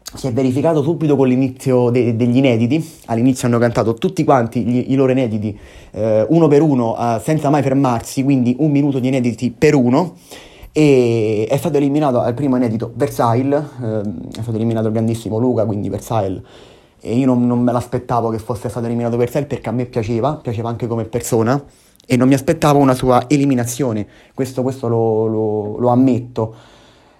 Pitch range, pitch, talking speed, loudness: 115-135 Hz, 125 Hz, 180 wpm, -16 LUFS